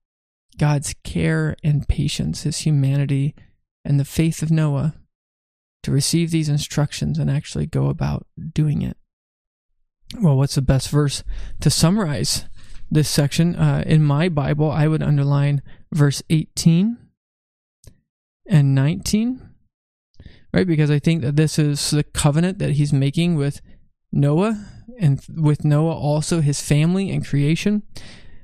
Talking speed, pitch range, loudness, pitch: 135 wpm, 140-160 Hz, -20 LUFS, 150 Hz